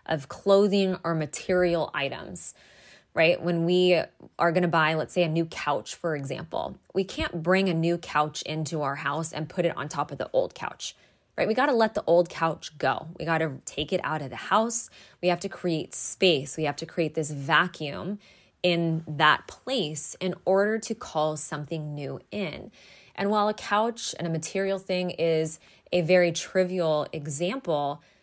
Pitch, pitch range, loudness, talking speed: 170 Hz, 155-185 Hz, -26 LUFS, 185 wpm